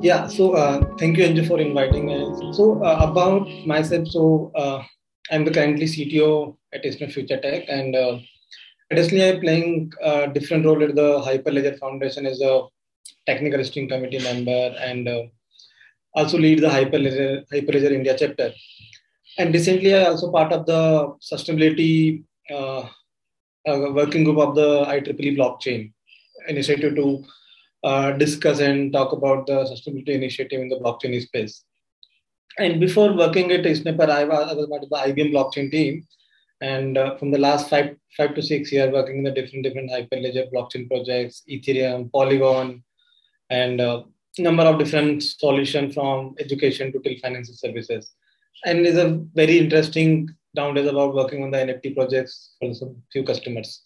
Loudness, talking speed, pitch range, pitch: -20 LUFS, 160 wpm, 135-155 Hz, 145 Hz